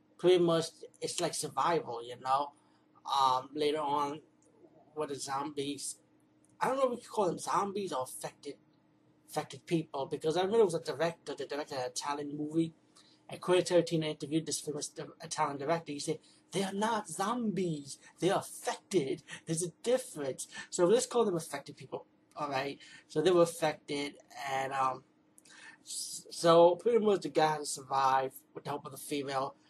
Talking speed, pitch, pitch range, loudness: 165 wpm, 155 Hz, 140-170 Hz, -33 LUFS